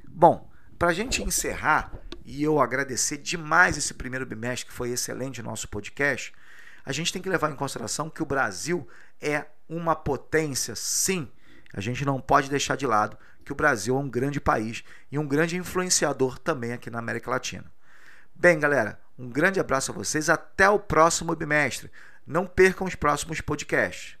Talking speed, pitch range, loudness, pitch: 175 wpm, 125-160 Hz, -25 LUFS, 145 Hz